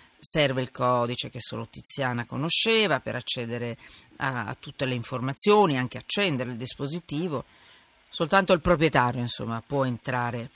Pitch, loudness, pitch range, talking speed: 130 Hz, -25 LUFS, 125-165 Hz, 135 wpm